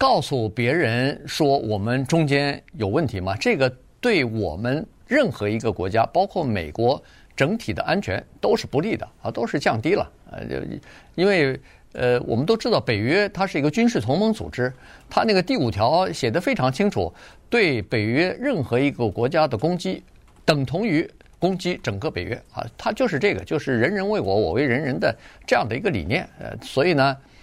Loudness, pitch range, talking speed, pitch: -22 LUFS, 120-180 Hz, 280 characters per minute, 135 Hz